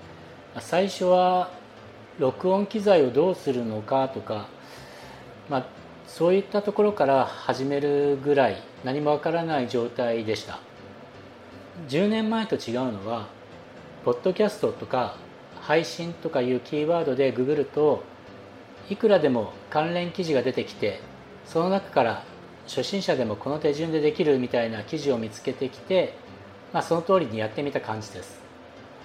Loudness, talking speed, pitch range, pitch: -25 LUFS, 285 characters per minute, 115-180 Hz, 145 Hz